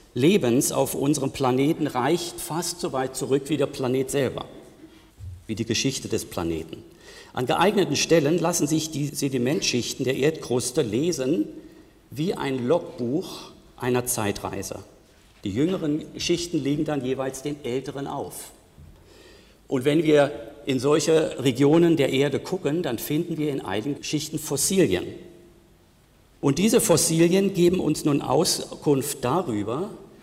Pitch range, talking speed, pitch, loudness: 130-165 Hz, 130 wpm, 145 Hz, -24 LUFS